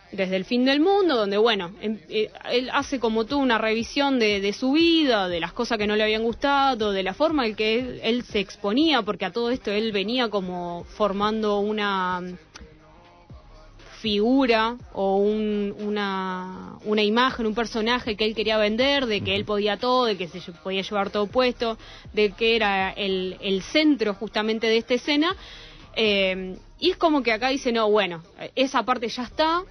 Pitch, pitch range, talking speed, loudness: 220 Hz, 205-250 Hz, 180 wpm, -23 LUFS